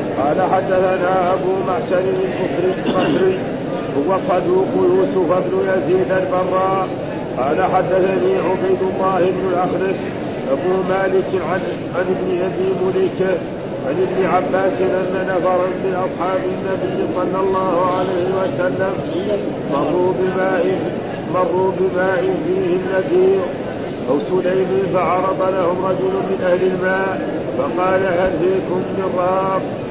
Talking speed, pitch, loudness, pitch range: 105 wpm, 185 Hz, -18 LUFS, 180-190 Hz